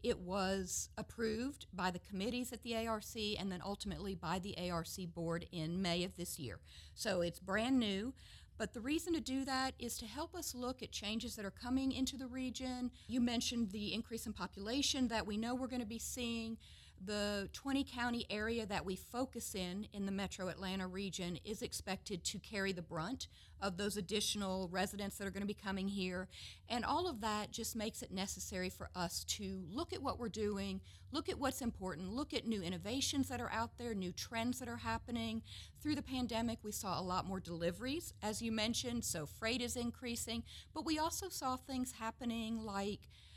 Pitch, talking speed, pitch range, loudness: 220 Hz, 200 wpm, 190-245 Hz, -41 LUFS